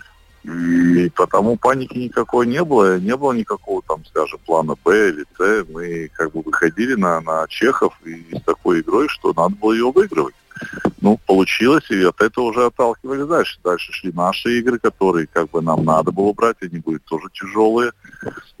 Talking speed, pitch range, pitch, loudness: 175 wpm, 85-125 Hz, 100 Hz, -18 LUFS